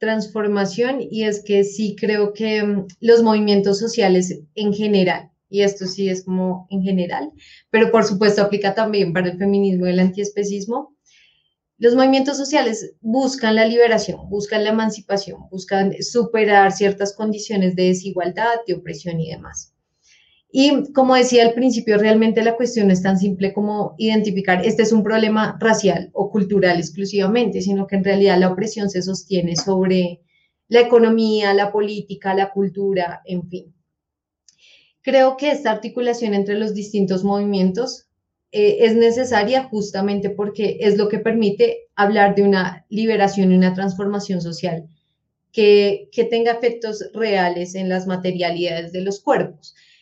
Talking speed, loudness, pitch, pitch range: 150 wpm, -18 LUFS, 205 Hz, 190-225 Hz